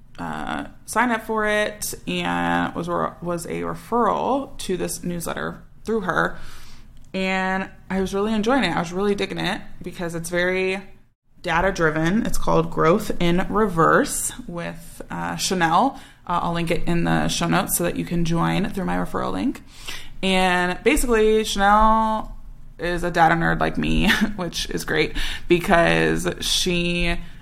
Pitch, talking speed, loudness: 170 Hz, 155 wpm, -22 LUFS